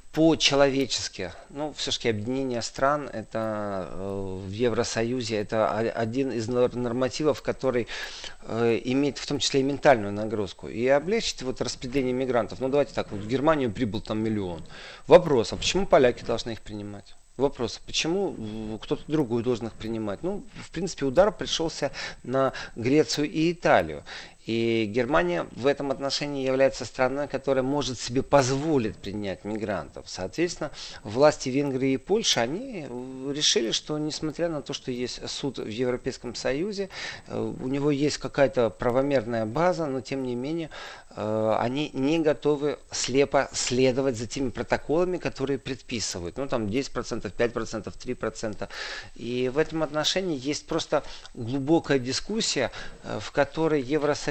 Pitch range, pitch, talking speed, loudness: 115-145 Hz, 130 Hz, 140 wpm, -26 LUFS